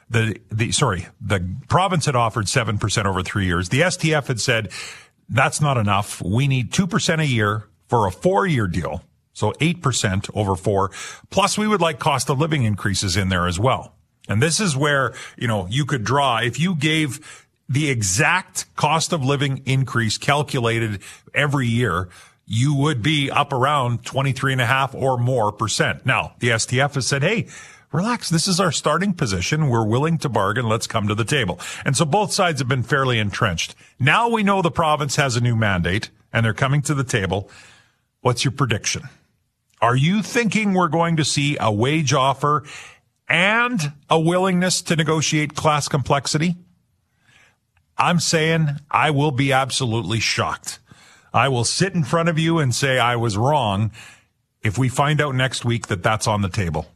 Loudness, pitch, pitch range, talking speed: -20 LUFS, 135 Hz, 115-155 Hz, 175 wpm